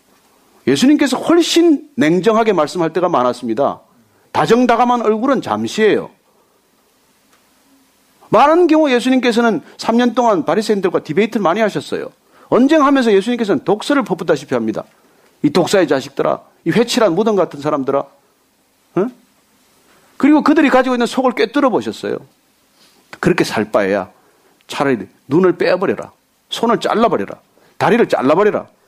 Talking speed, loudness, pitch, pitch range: 325 characters per minute, -15 LUFS, 240 Hz, 195-275 Hz